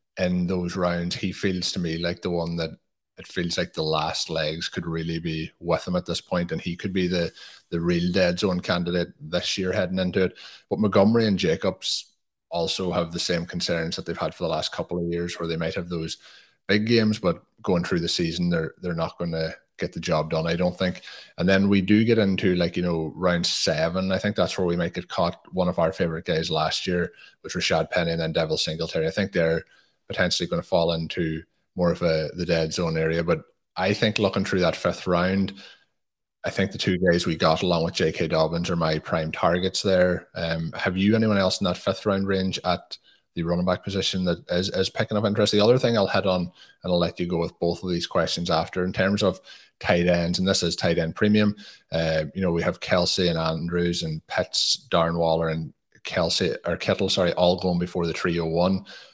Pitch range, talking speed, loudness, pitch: 85-95 Hz, 230 wpm, -24 LUFS, 90 Hz